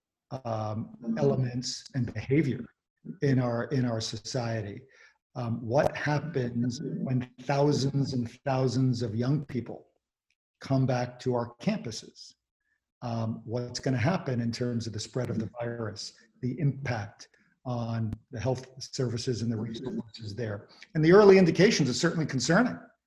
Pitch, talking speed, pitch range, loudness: 125 Hz, 140 wpm, 115-140 Hz, -29 LUFS